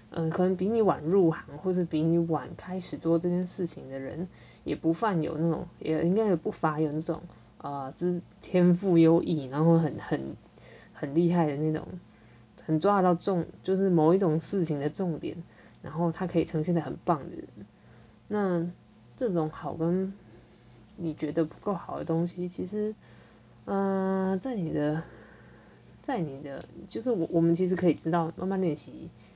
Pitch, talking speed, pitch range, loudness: 170 Hz, 245 characters per minute, 155-185 Hz, -29 LUFS